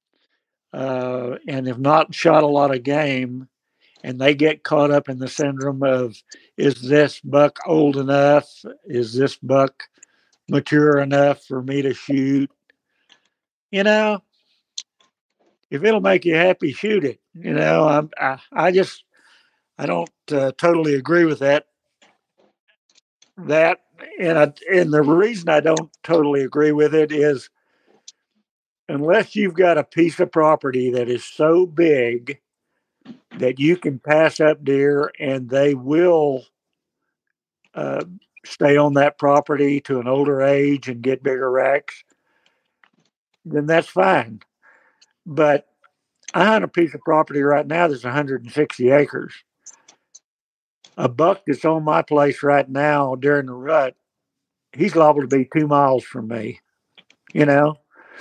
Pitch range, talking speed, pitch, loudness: 135-155 Hz, 140 wpm, 145 Hz, -18 LUFS